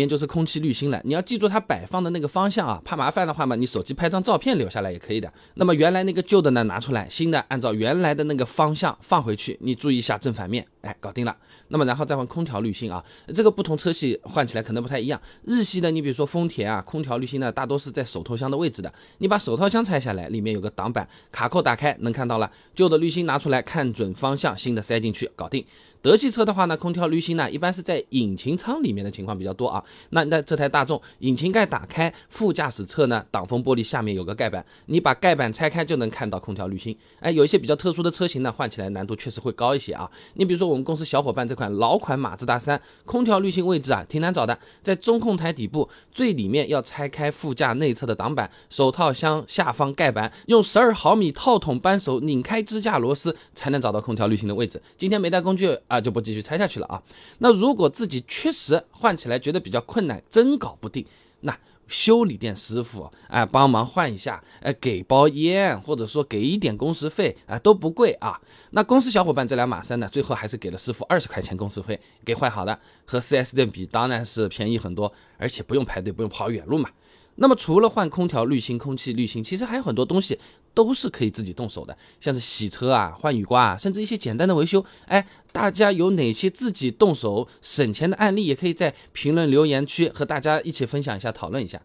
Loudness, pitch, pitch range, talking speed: -23 LUFS, 140 Hz, 115-175 Hz, 360 characters per minute